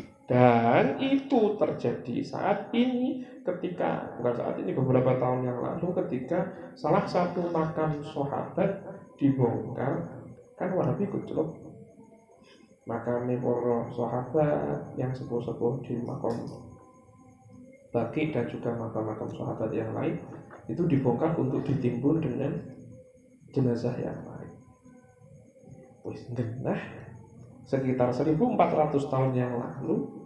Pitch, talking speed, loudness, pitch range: 130 Hz, 100 wpm, -29 LUFS, 120-160 Hz